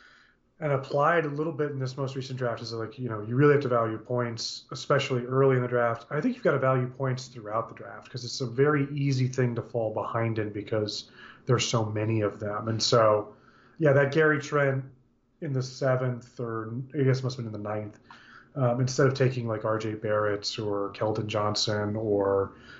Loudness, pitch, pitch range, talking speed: -27 LUFS, 120 Hz, 110-135 Hz, 215 wpm